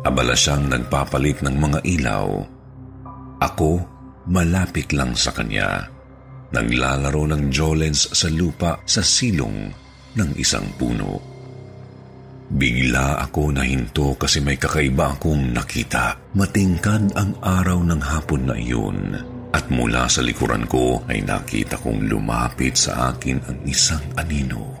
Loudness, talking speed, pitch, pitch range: -20 LUFS, 120 wpm, 70 Hz, 65-90 Hz